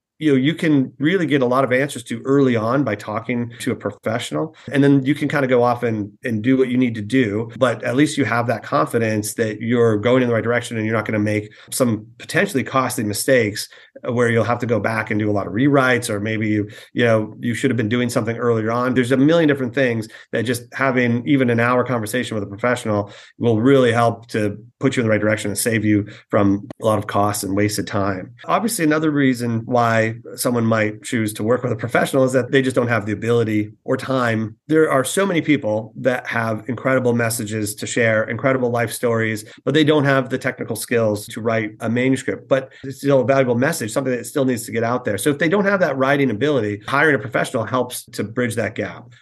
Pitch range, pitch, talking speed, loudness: 110-130 Hz, 120 Hz, 240 wpm, -19 LUFS